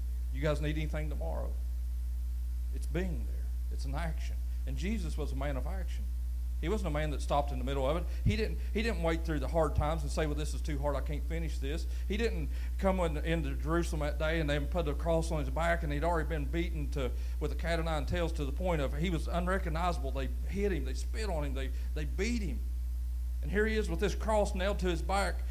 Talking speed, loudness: 250 wpm, -34 LUFS